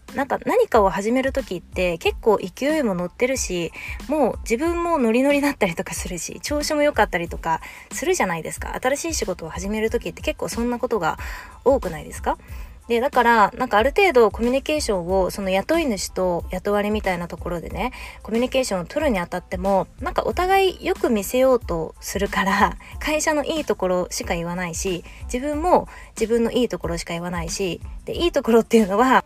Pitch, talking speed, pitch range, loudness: 230 Hz, 425 characters per minute, 190-275 Hz, -22 LUFS